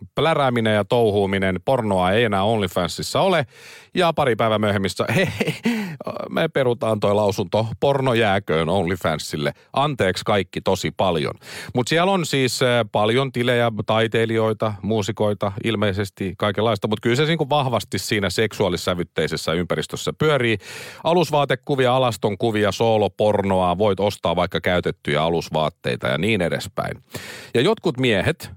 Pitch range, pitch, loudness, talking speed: 105-125 Hz, 110 Hz, -21 LUFS, 120 wpm